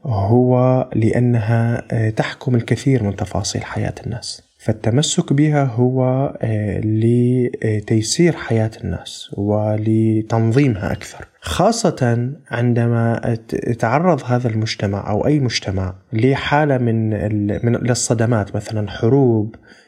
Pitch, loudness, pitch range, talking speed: 115 Hz, -18 LUFS, 110-125 Hz, 90 wpm